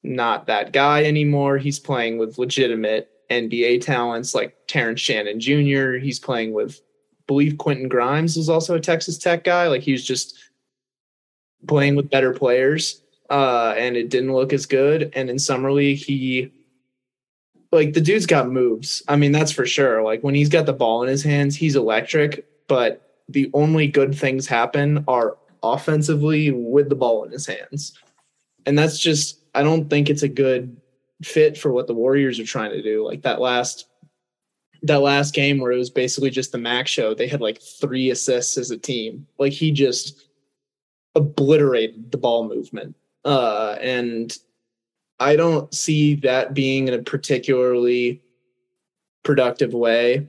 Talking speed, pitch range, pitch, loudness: 170 wpm, 125-145 Hz, 135 Hz, -20 LUFS